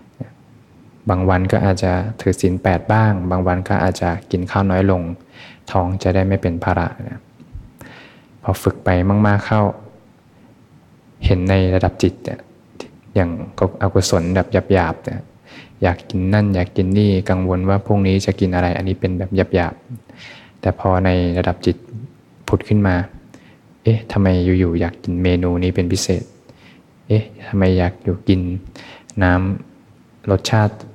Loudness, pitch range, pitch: -18 LUFS, 90-100 Hz, 95 Hz